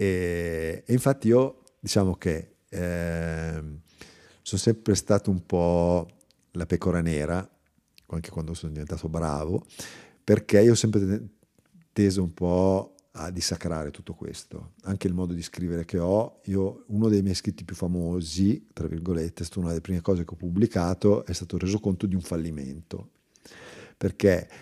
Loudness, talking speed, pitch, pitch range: -26 LUFS, 155 wpm, 90 Hz, 85-100 Hz